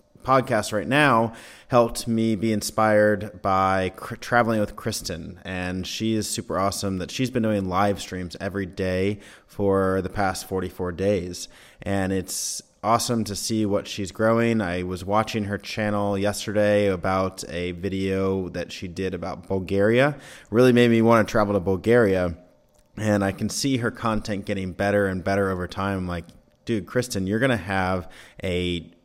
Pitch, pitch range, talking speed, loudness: 100 Hz, 95-110 Hz, 165 wpm, -24 LUFS